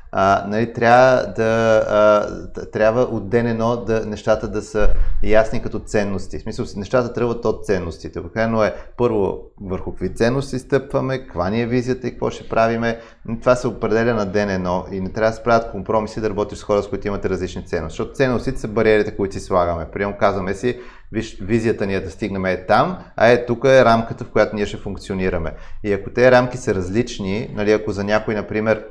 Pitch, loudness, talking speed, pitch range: 110 Hz, -19 LUFS, 210 wpm, 100-115 Hz